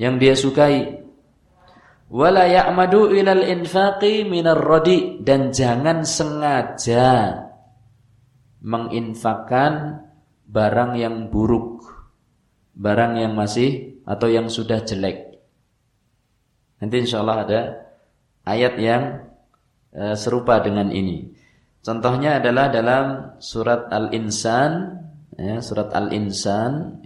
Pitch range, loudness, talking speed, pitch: 110-150 Hz, -19 LUFS, 90 wpm, 120 Hz